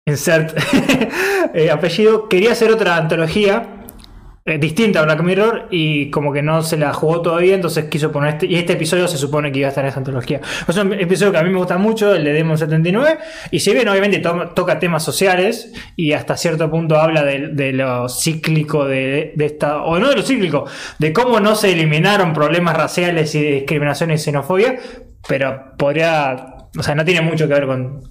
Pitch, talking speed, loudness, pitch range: 165 Hz, 205 wpm, -16 LUFS, 150-195 Hz